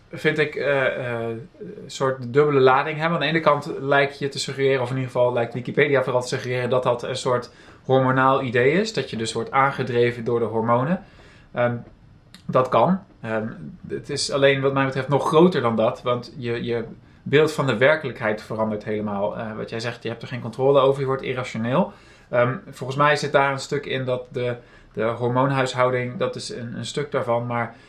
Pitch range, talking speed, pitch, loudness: 120-140 Hz, 205 wpm, 130 Hz, -22 LUFS